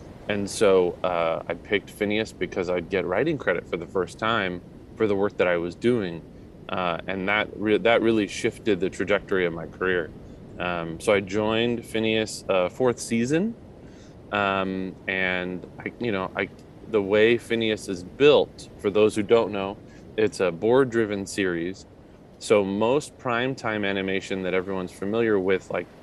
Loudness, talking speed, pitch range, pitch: -25 LUFS, 165 wpm, 90-110 Hz, 100 Hz